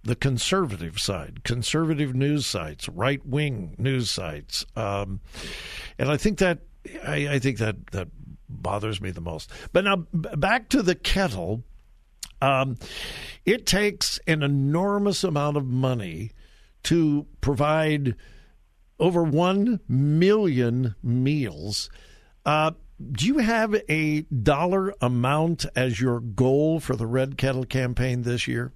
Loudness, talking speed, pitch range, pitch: -25 LUFS, 130 wpm, 115-160 Hz, 135 Hz